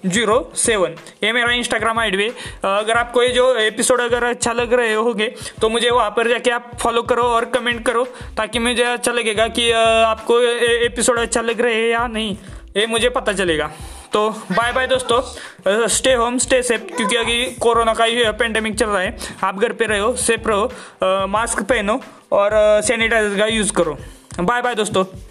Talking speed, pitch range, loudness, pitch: 185 wpm, 220-240 Hz, -17 LUFS, 235 Hz